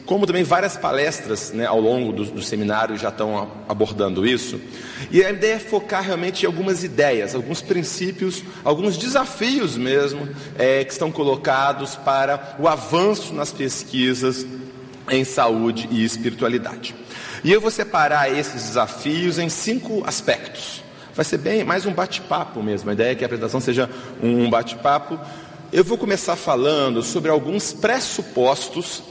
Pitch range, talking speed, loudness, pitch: 125-185 Hz, 150 wpm, -21 LUFS, 140 Hz